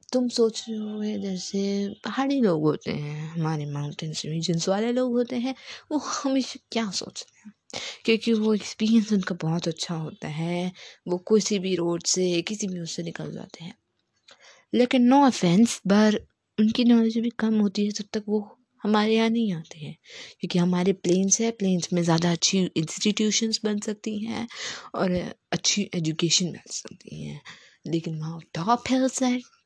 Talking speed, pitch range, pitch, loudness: 165 wpm, 175-230 Hz, 205 Hz, -25 LUFS